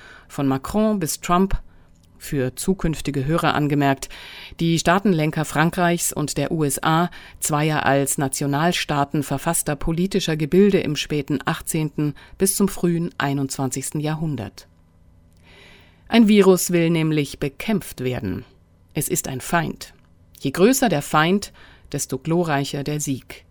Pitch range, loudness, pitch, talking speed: 135-170 Hz, -21 LUFS, 150 Hz, 115 wpm